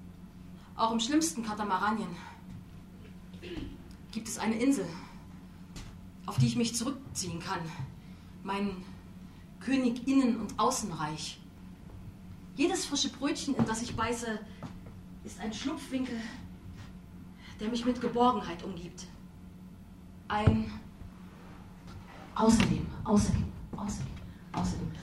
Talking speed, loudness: 95 wpm, -32 LUFS